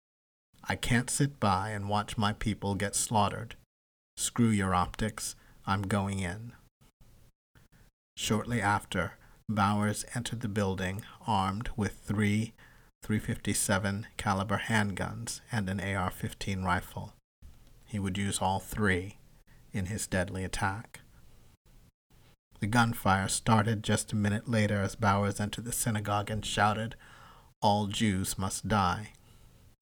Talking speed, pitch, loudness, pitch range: 120 wpm, 105 Hz, -31 LUFS, 100-115 Hz